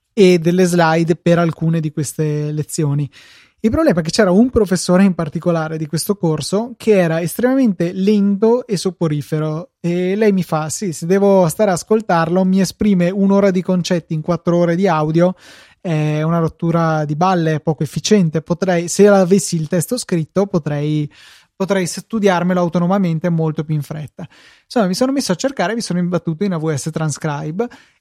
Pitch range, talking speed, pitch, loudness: 160-195 Hz, 170 wpm, 175 Hz, -16 LUFS